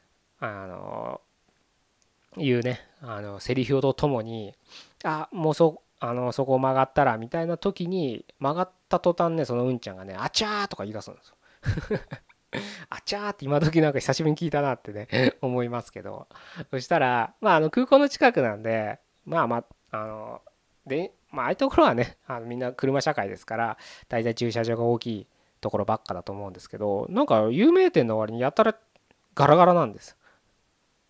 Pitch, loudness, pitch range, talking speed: 130 Hz, -25 LUFS, 115-165 Hz, 355 characters per minute